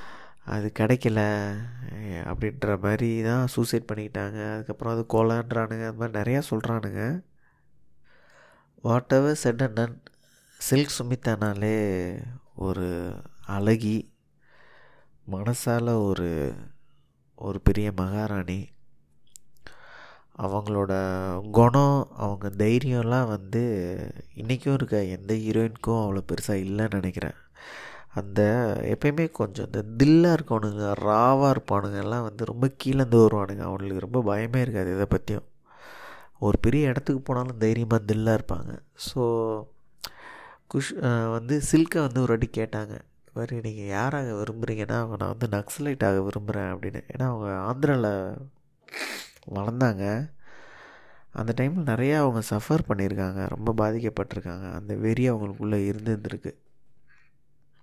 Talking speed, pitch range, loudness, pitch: 105 wpm, 100-125 Hz, -26 LUFS, 110 Hz